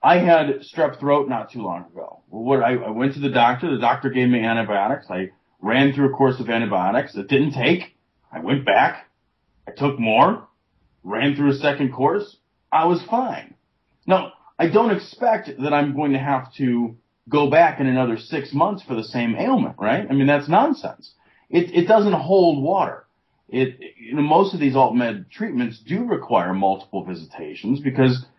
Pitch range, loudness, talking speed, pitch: 120-160 Hz, -20 LUFS, 180 wpm, 135 Hz